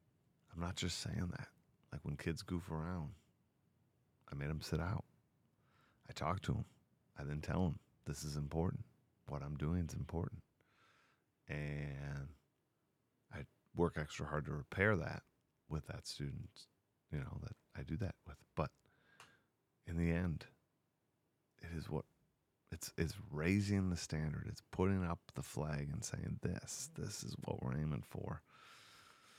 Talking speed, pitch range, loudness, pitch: 155 wpm, 75-95 Hz, -43 LUFS, 85 Hz